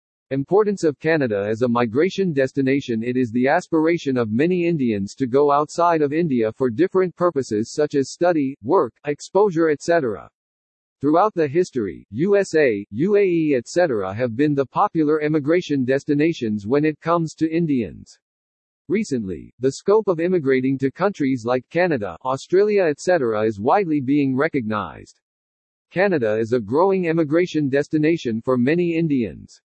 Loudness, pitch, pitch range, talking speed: -20 LUFS, 145 Hz, 125-170 Hz, 140 wpm